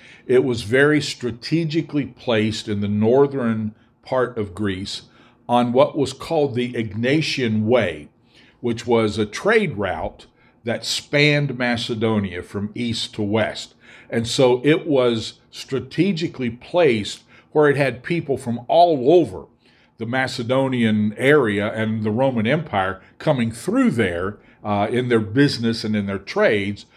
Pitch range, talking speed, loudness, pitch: 110-140 Hz, 135 wpm, -20 LUFS, 120 Hz